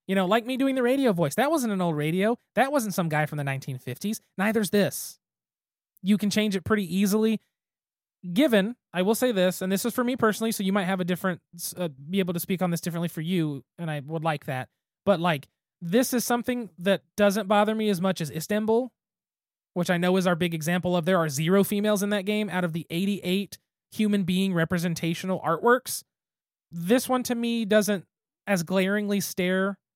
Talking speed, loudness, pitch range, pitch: 210 wpm, -26 LUFS, 175-215 Hz, 195 Hz